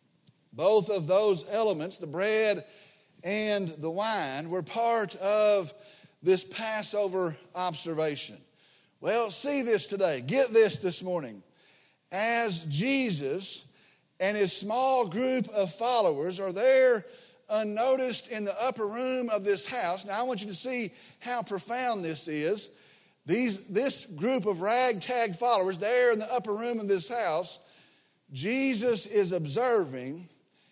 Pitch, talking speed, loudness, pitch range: 205 Hz, 135 wpm, -27 LUFS, 185-235 Hz